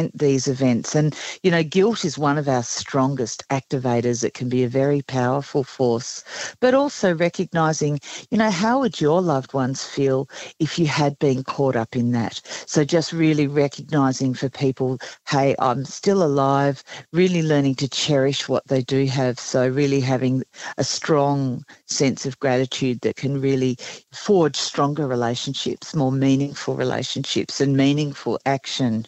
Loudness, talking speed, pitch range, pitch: -21 LUFS, 155 wpm, 130-150 Hz, 135 Hz